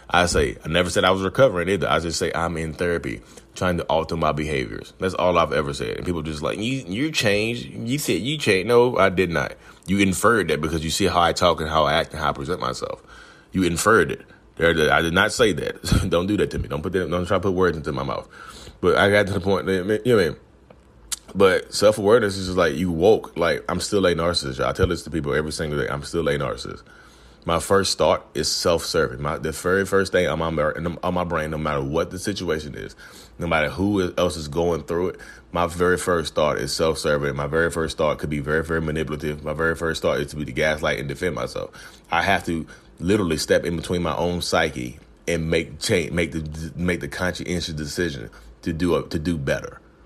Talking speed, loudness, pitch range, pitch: 240 wpm, -22 LUFS, 75-95 Hz, 85 Hz